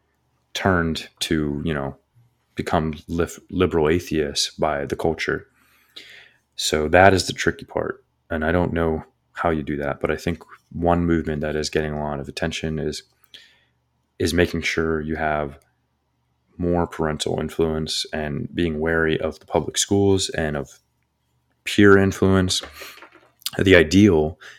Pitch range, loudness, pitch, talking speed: 75-85 Hz, -21 LUFS, 80 Hz, 140 wpm